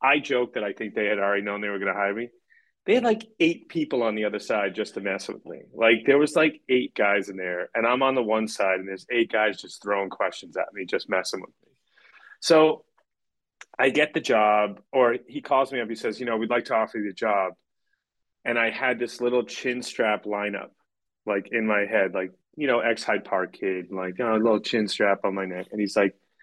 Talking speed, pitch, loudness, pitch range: 250 wpm, 110 Hz, -25 LUFS, 100-125 Hz